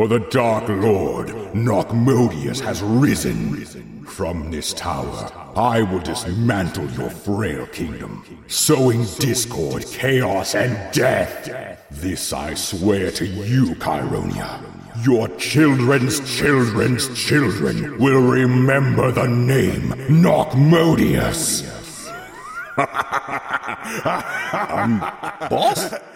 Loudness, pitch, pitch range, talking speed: -19 LUFS, 120 Hz, 95-130 Hz, 85 wpm